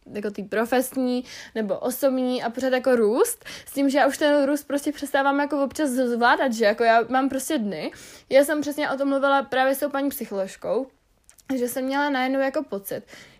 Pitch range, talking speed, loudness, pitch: 245-280 Hz, 195 wpm, -23 LUFS, 265 Hz